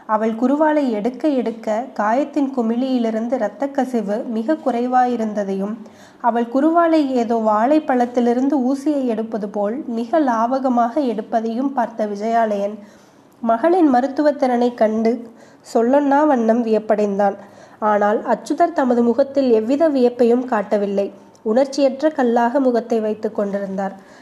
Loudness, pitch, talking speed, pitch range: -18 LUFS, 235 Hz, 100 wpm, 220-270 Hz